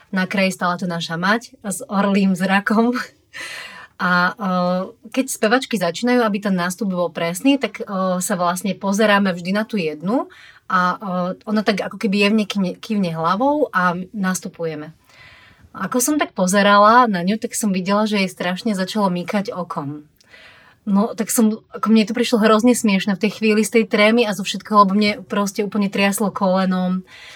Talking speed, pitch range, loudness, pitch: 175 wpm, 185-220 Hz, -18 LUFS, 200 Hz